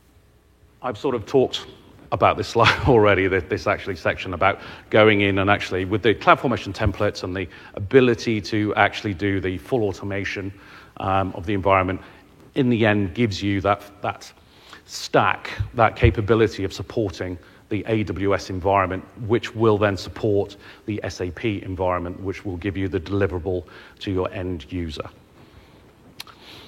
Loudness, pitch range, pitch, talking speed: -22 LUFS, 95-110 Hz, 100 Hz, 150 wpm